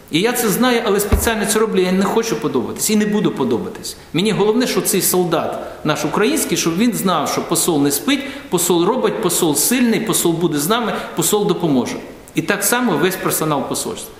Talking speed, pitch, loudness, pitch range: 195 wpm, 210 Hz, -17 LUFS, 180-230 Hz